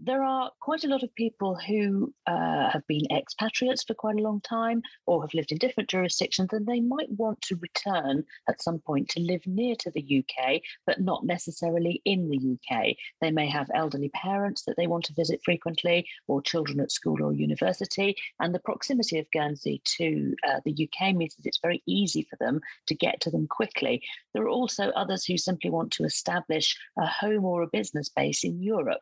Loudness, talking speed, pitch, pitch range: -28 LUFS, 205 wpm, 180 Hz, 155-215 Hz